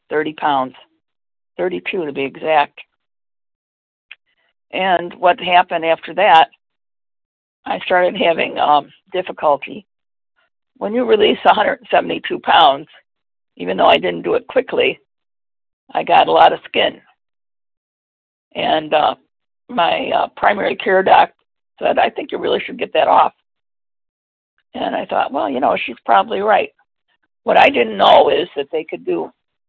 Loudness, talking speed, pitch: -16 LUFS, 150 wpm, 170 Hz